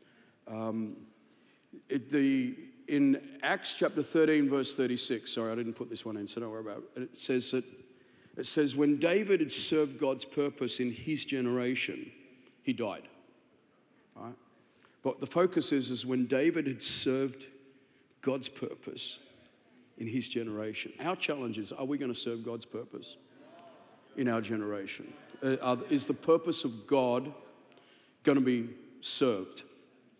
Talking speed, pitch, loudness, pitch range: 155 wpm, 130 Hz, -31 LUFS, 120-145 Hz